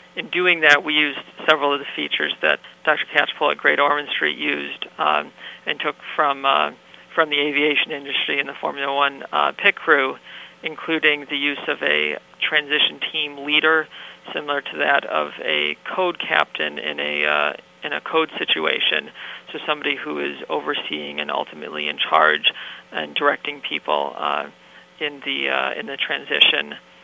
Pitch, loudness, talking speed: 140 Hz, -20 LUFS, 165 wpm